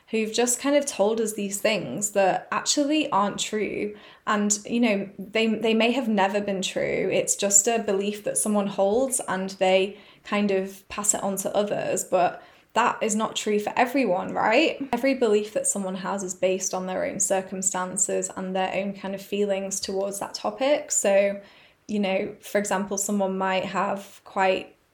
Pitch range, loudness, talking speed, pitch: 195-220 Hz, -24 LUFS, 180 wpm, 200 Hz